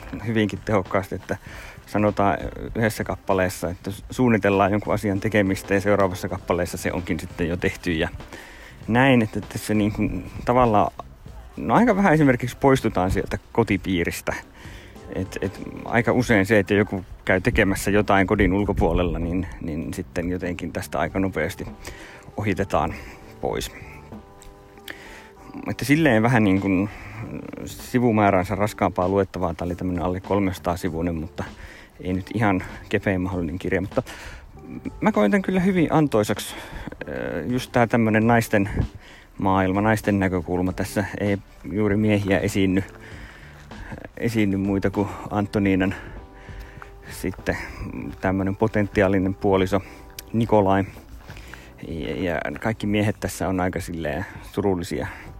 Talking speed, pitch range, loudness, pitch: 120 wpm, 95-105 Hz, -23 LUFS, 100 Hz